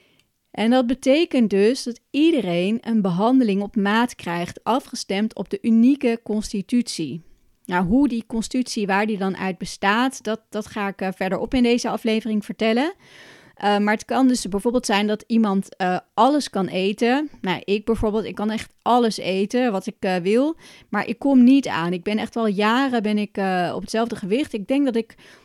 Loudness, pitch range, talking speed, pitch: -21 LUFS, 200-245 Hz, 185 wpm, 220 Hz